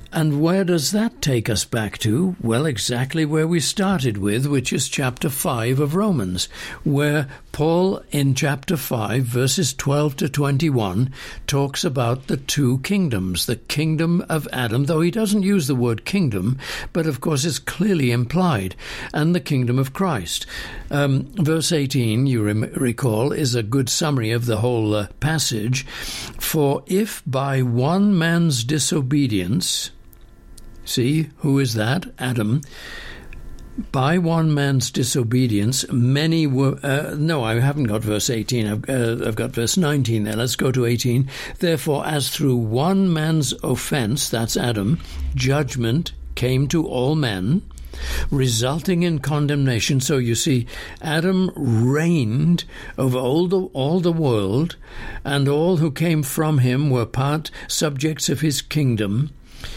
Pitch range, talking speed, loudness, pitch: 120-160 Hz, 145 wpm, -20 LUFS, 140 Hz